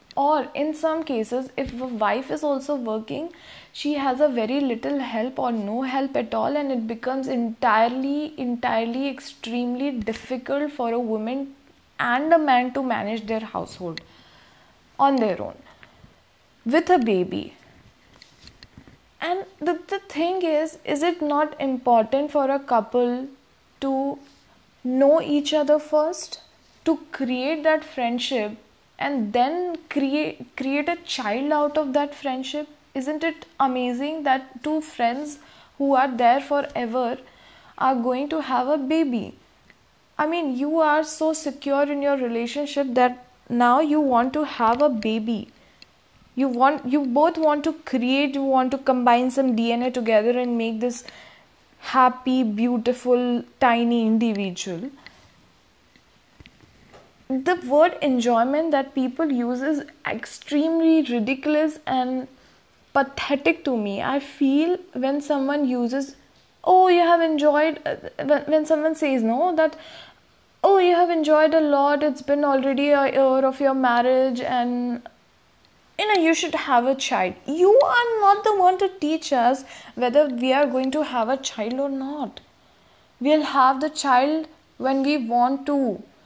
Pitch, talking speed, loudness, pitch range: 275 Hz, 140 wpm, -22 LUFS, 250-300 Hz